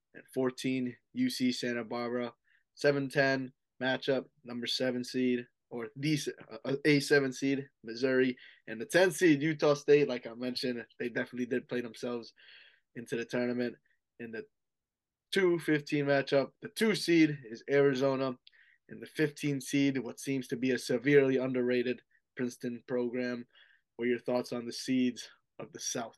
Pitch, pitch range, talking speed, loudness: 130 Hz, 125-145 Hz, 145 wpm, -32 LUFS